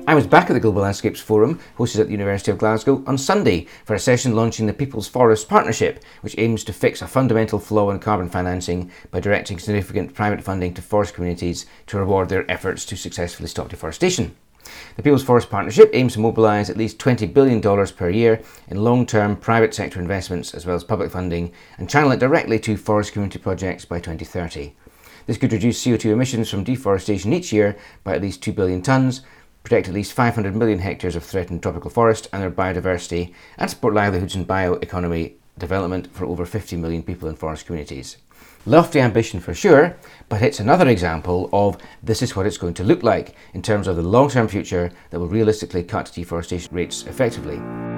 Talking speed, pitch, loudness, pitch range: 195 wpm, 100 Hz, -20 LUFS, 90-110 Hz